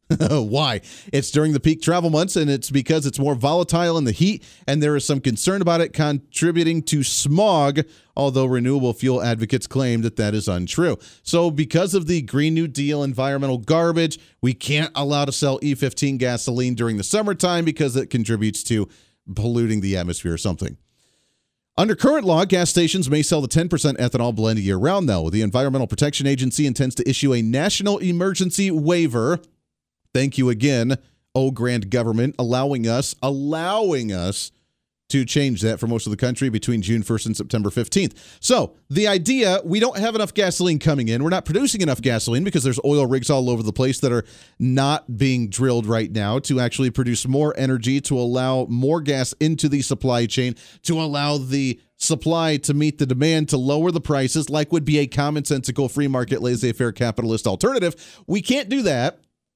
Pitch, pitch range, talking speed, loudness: 140 Hz, 120-160 Hz, 180 wpm, -20 LUFS